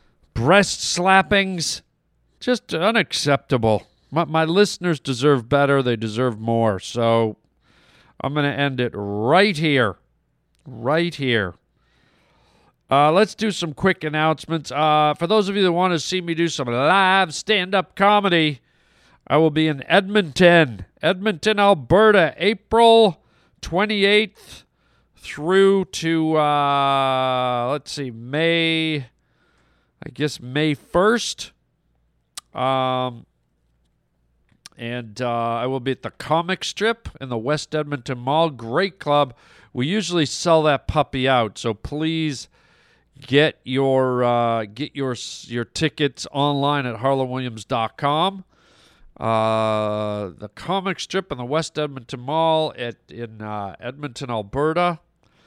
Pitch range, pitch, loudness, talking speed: 120-170 Hz, 145 Hz, -20 LUFS, 120 wpm